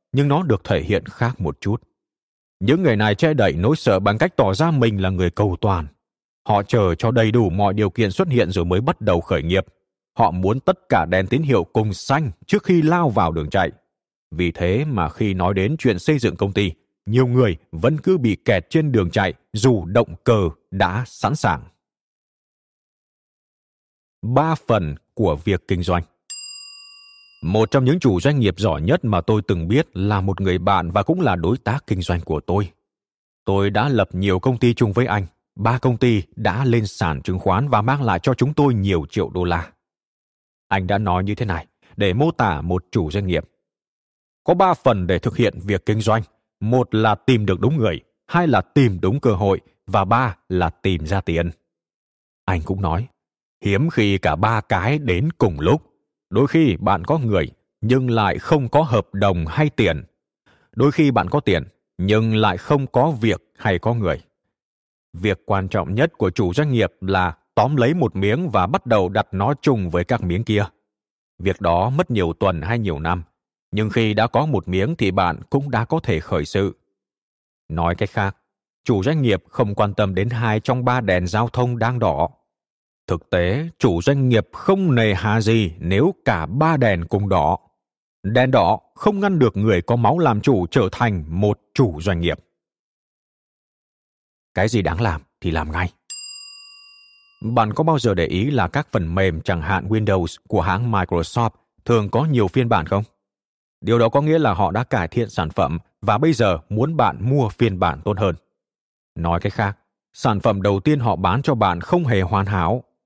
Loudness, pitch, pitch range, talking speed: -20 LUFS, 105 Hz, 95-125 Hz, 200 wpm